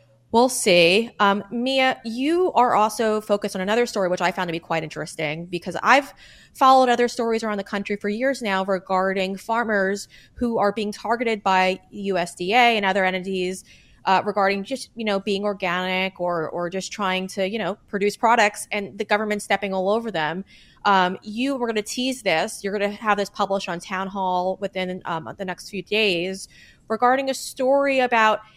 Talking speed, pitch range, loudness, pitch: 185 wpm, 185-225 Hz, -22 LUFS, 205 Hz